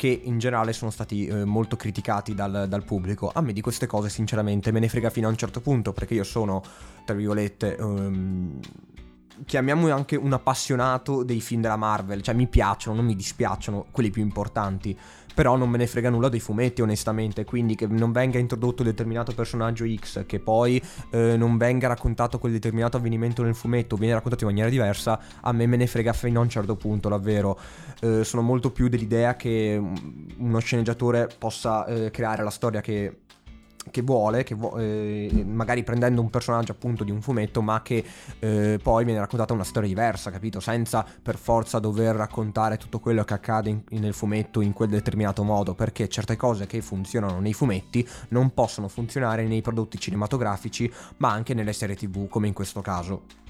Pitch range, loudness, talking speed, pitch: 105-120 Hz, -25 LUFS, 190 wpm, 110 Hz